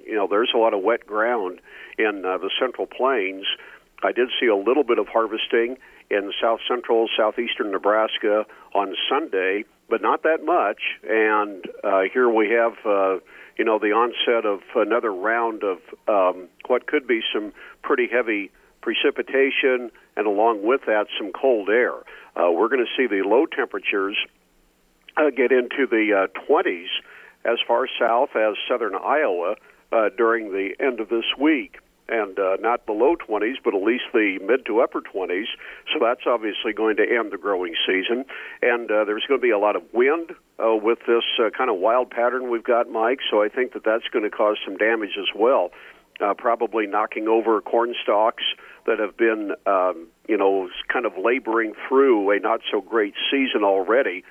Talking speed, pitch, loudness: 180 wpm, 115 Hz, -22 LUFS